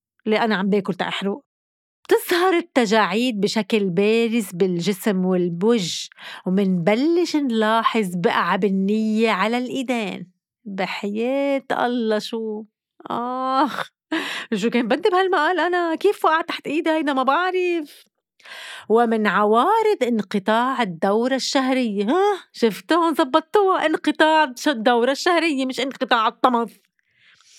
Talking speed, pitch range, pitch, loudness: 100 wpm, 210-310 Hz, 240 Hz, -20 LUFS